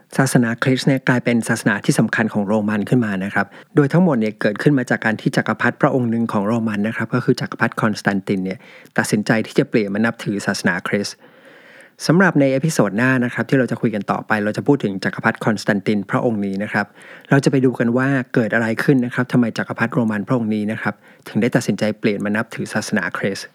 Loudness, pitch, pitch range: -19 LUFS, 120 Hz, 110-130 Hz